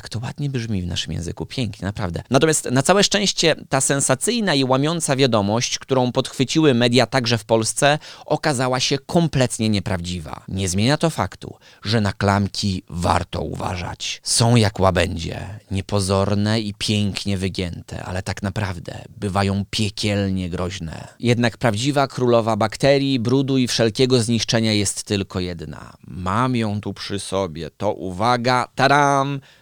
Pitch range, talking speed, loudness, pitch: 95-130 Hz, 140 wpm, -20 LUFS, 110 Hz